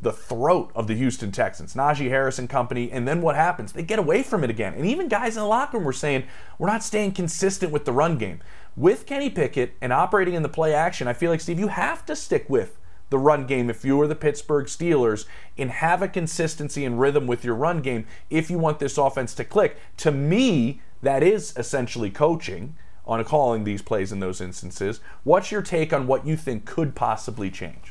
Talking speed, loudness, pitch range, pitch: 225 wpm, -24 LUFS, 120-165 Hz, 145 Hz